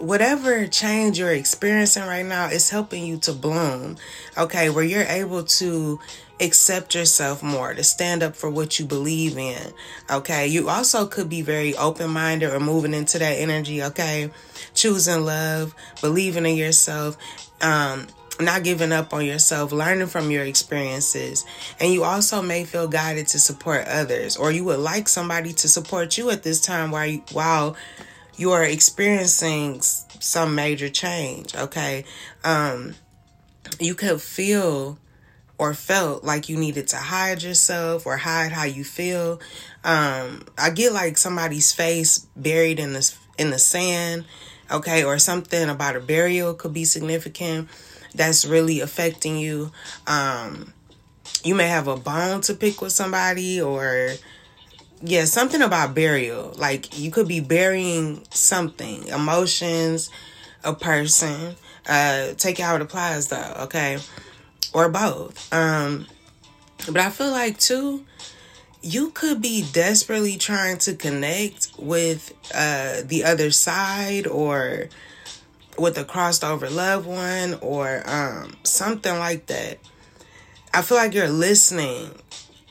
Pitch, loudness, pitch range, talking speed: 160 Hz, -20 LUFS, 150-180 Hz, 140 wpm